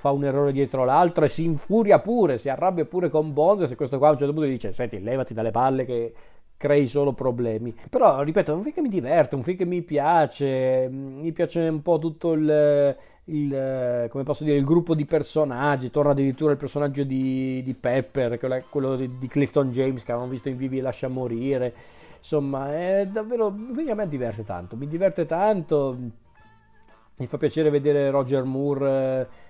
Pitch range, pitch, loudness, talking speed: 130-155 Hz, 140 Hz, -23 LUFS, 185 wpm